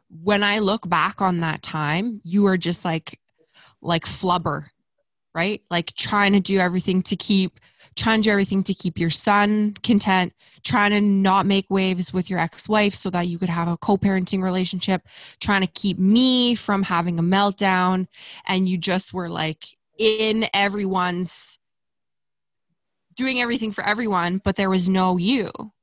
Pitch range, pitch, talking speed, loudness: 180-205 Hz, 190 Hz, 165 wpm, -21 LUFS